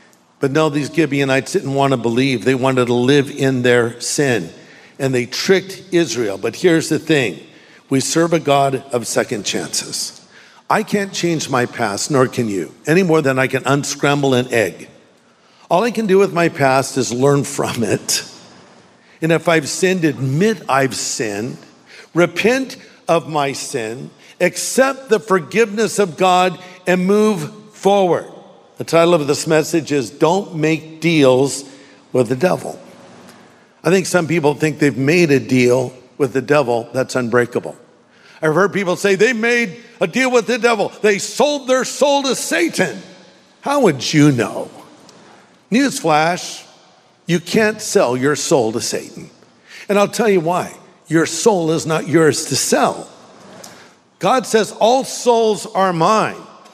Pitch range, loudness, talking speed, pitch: 135-195 Hz, -16 LUFS, 160 wpm, 160 Hz